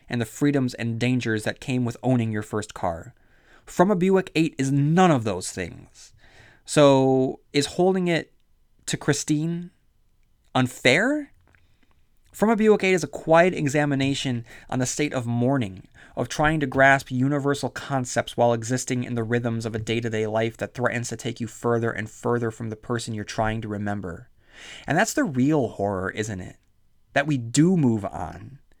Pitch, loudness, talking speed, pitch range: 125 Hz, -23 LUFS, 175 wpm, 115-145 Hz